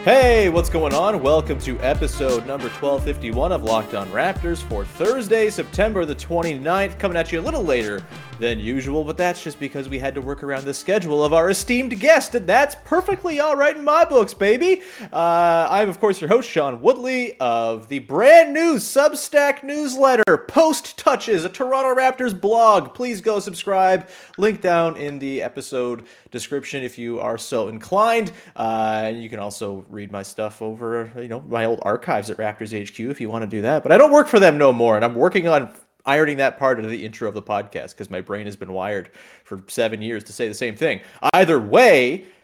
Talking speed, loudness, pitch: 205 wpm, -19 LUFS, 160 Hz